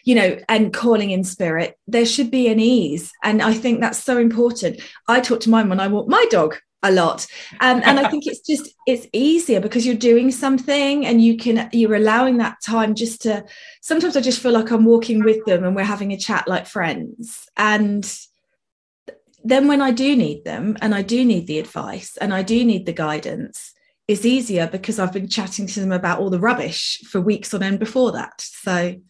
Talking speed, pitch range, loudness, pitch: 210 wpm, 205-245 Hz, -18 LUFS, 230 Hz